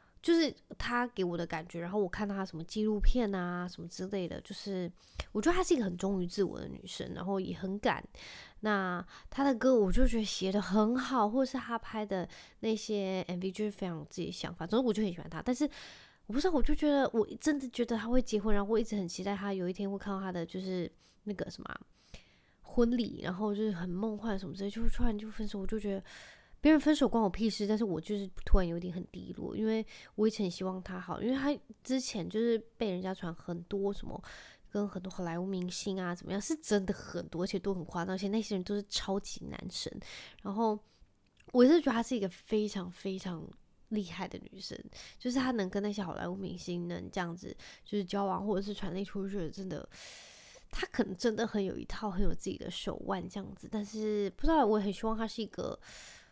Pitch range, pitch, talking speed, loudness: 185-225 Hz, 205 Hz, 330 characters per minute, -34 LUFS